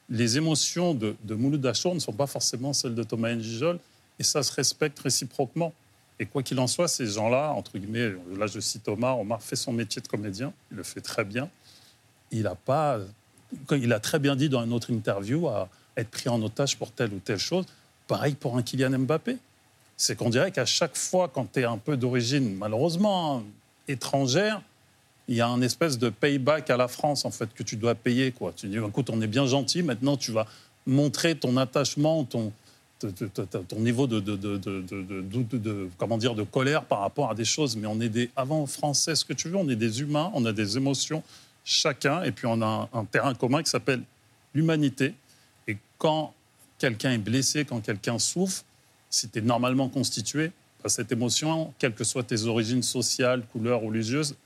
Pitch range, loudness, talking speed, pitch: 115-145 Hz, -27 LUFS, 195 wpm, 125 Hz